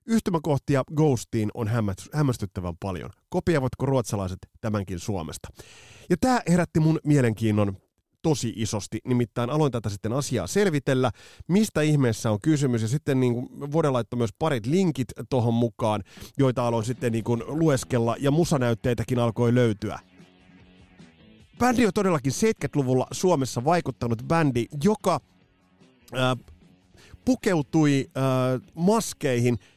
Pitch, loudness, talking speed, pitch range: 125 Hz, -25 LUFS, 115 wpm, 110-150 Hz